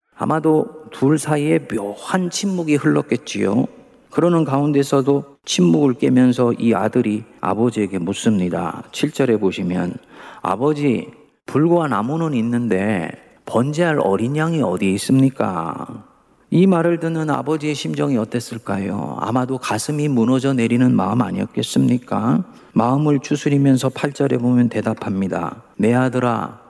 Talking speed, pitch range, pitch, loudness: 300 characters per minute, 110-150 Hz, 130 Hz, -19 LUFS